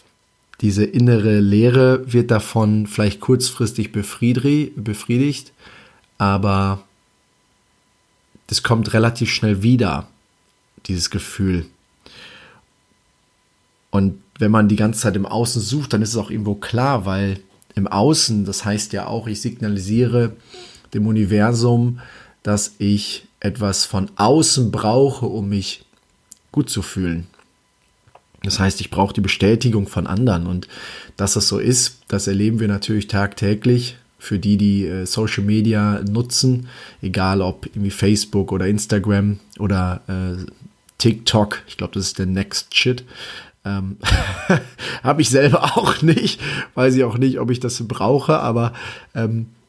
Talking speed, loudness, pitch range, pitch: 135 wpm, -18 LUFS, 100-120 Hz, 105 Hz